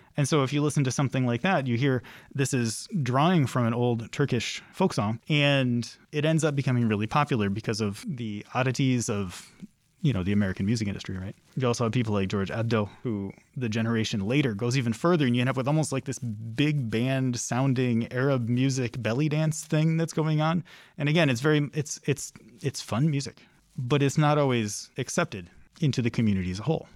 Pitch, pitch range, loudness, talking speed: 130 Hz, 115-150 Hz, -27 LUFS, 205 wpm